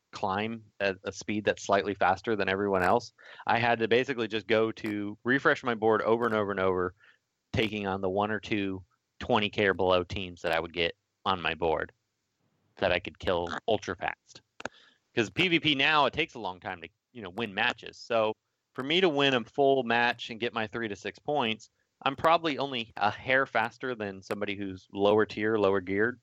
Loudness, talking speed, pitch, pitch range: -29 LUFS, 205 wpm, 110 Hz, 100-120 Hz